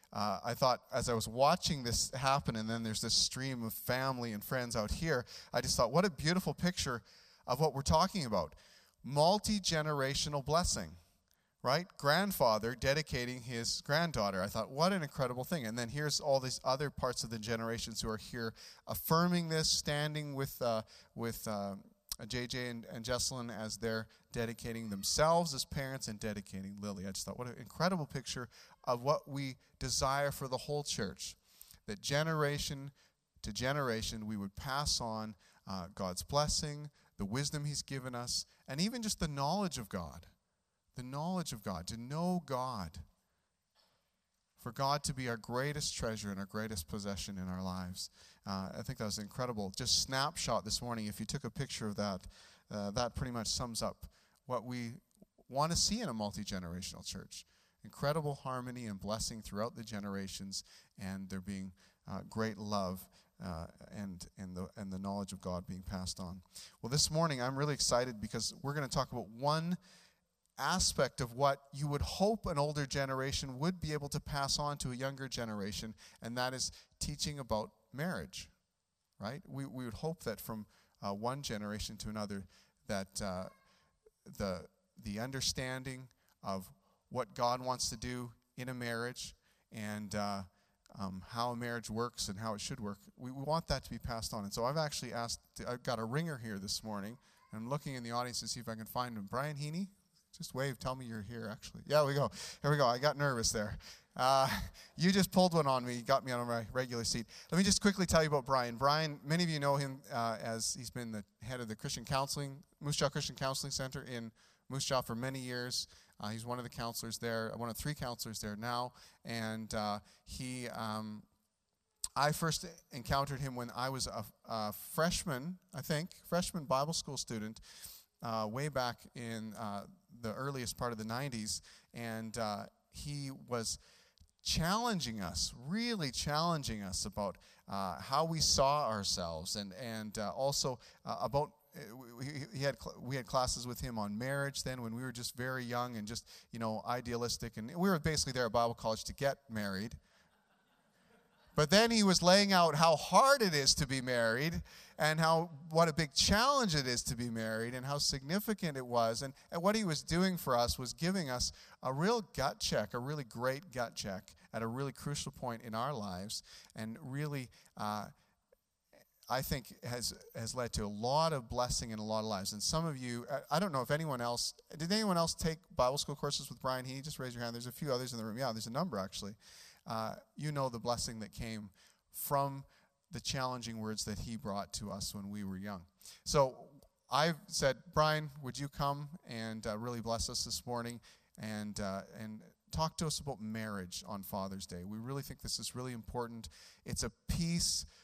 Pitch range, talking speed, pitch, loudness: 110-145 Hz, 190 wpm, 125 Hz, -37 LUFS